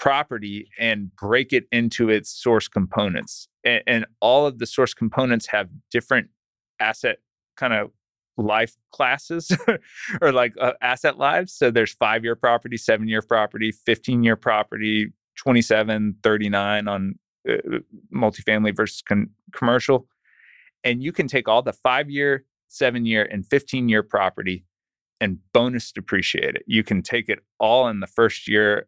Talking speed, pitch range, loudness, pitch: 150 wpm, 105-125 Hz, -21 LUFS, 110 Hz